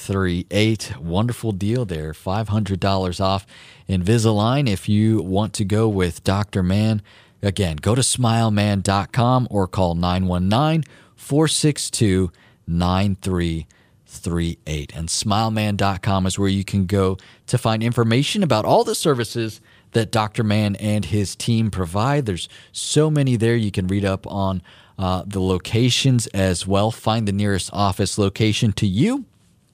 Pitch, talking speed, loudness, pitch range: 105 Hz, 135 wpm, -20 LUFS, 95-115 Hz